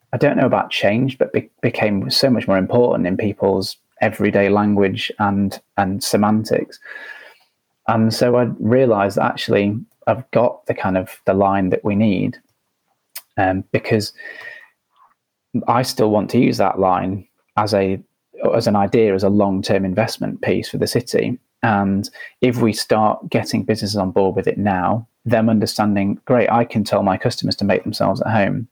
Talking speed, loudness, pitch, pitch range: 170 wpm, -18 LUFS, 105 Hz, 100-115 Hz